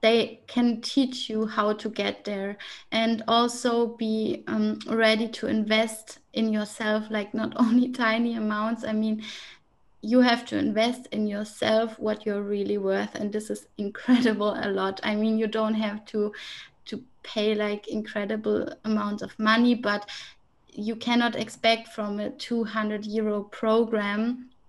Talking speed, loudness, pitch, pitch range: 150 wpm, -26 LUFS, 220 Hz, 210-230 Hz